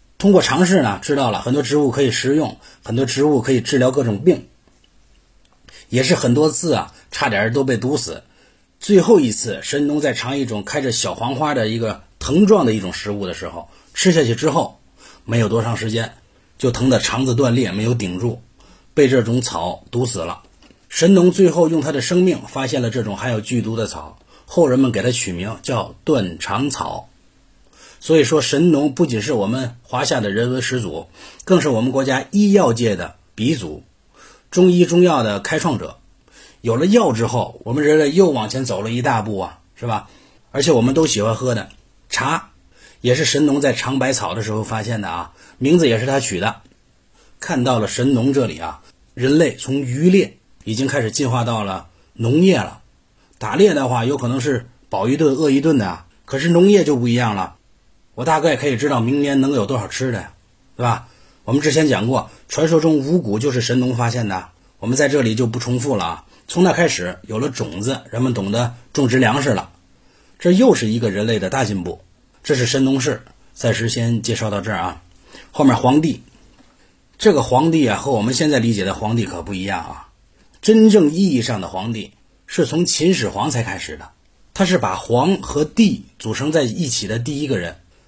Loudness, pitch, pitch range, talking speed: -17 LUFS, 125 Hz, 110-145 Hz, 280 characters per minute